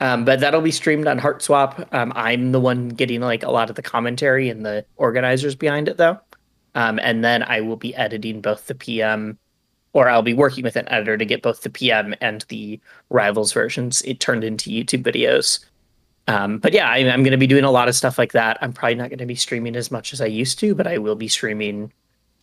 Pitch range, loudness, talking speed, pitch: 110-135 Hz, -19 LUFS, 235 wpm, 120 Hz